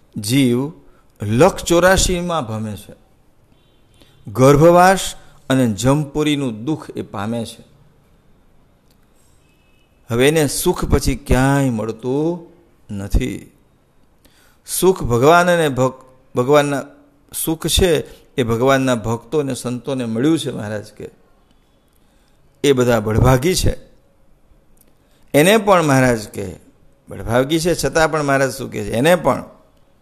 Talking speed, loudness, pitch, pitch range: 105 wpm, -16 LUFS, 130 Hz, 115-155 Hz